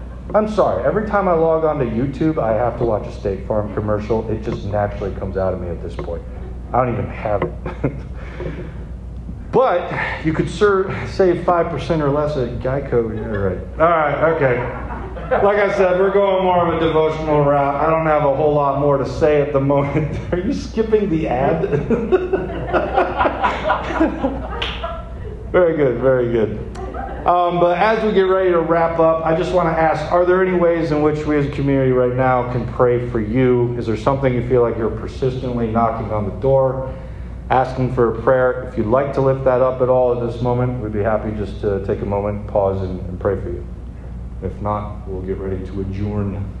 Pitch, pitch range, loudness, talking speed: 130 Hz, 110-160 Hz, -18 LUFS, 200 wpm